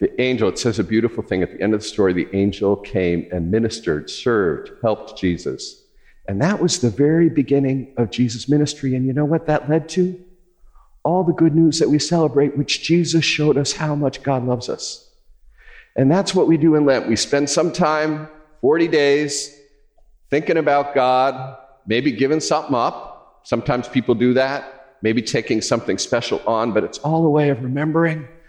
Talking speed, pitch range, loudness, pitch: 185 wpm, 130-165 Hz, -19 LUFS, 145 Hz